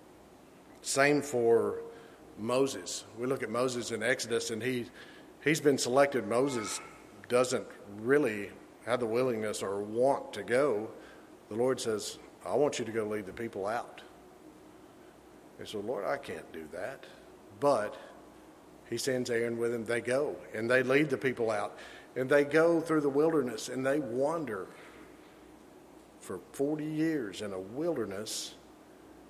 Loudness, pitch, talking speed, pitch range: -31 LUFS, 130 Hz, 145 wpm, 115-165 Hz